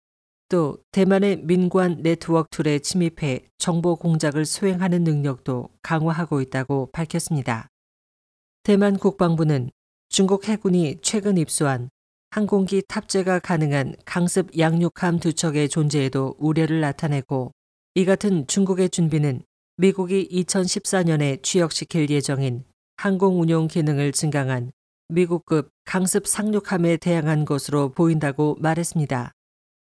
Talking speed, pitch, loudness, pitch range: 275 characters per minute, 165 Hz, -22 LUFS, 145-185 Hz